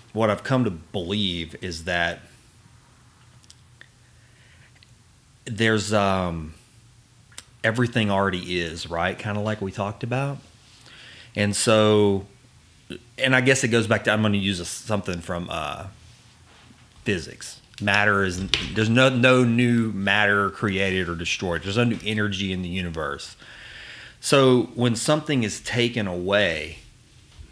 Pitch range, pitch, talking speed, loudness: 100-120 Hz, 110 Hz, 130 wpm, -22 LUFS